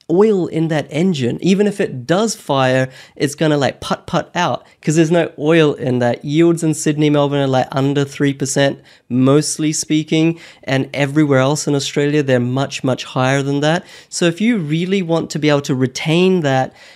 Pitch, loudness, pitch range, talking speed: 150 Hz, -16 LUFS, 135-165 Hz, 190 wpm